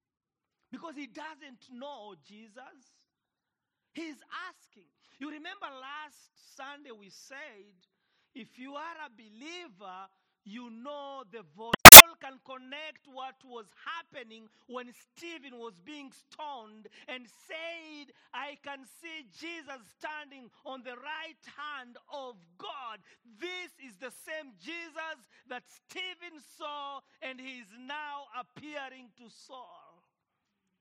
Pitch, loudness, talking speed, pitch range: 270 Hz, -5 LUFS, 120 wpm, 240-305 Hz